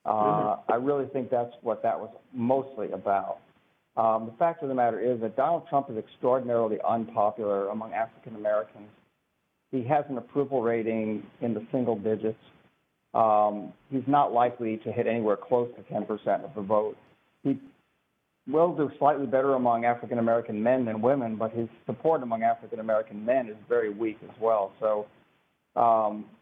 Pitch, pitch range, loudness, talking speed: 115 Hz, 110-135 Hz, -28 LUFS, 165 wpm